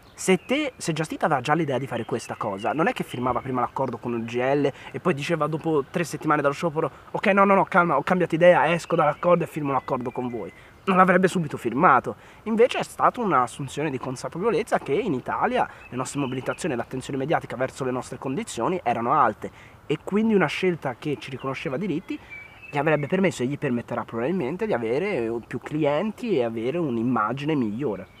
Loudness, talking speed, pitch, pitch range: -24 LUFS, 190 wpm, 145 Hz, 130-175 Hz